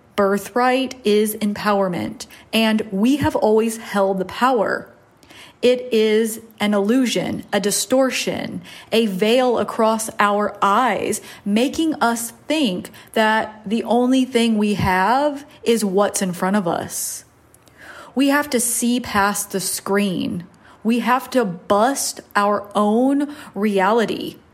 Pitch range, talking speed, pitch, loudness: 205-250 Hz, 120 wpm, 220 Hz, -19 LUFS